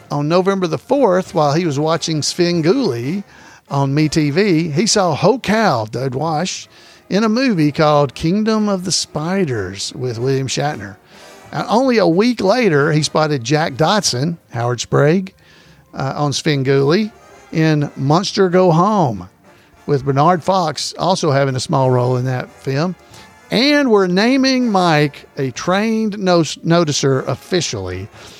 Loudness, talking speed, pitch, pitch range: -16 LUFS, 140 wpm, 155 Hz, 140-190 Hz